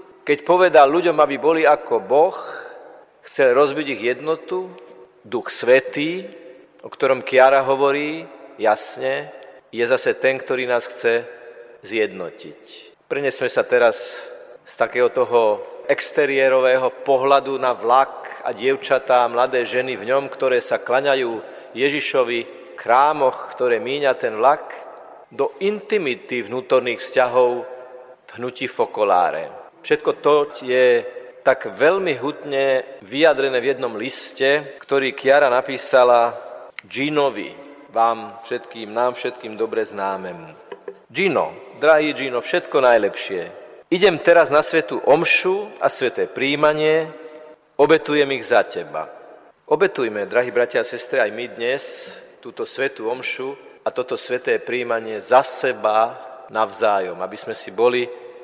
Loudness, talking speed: -19 LUFS, 120 wpm